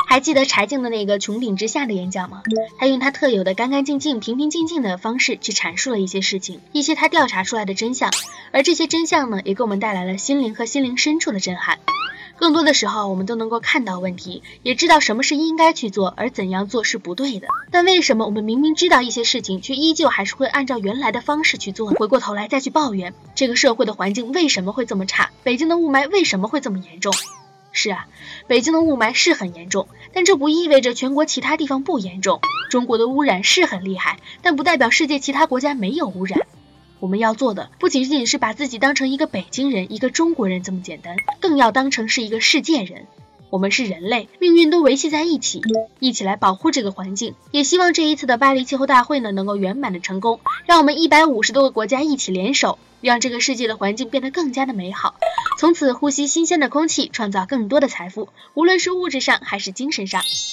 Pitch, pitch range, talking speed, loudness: 255 Hz, 205-305 Hz, 355 characters per minute, -18 LUFS